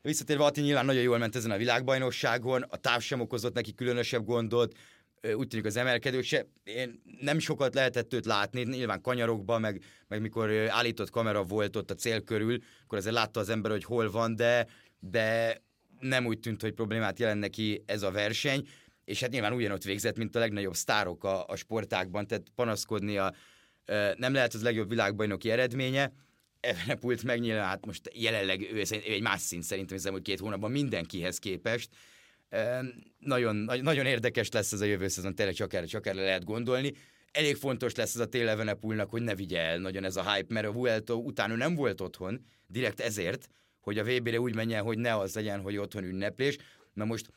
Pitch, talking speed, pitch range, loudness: 115 Hz, 185 wpm, 105-125 Hz, -31 LUFS